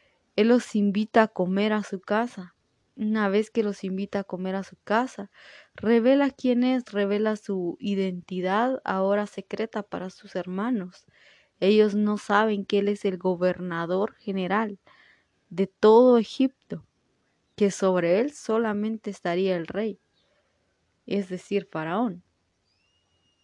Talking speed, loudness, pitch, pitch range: 130 wpm, -25 LUFS, 205 Hz, 185-220 Hz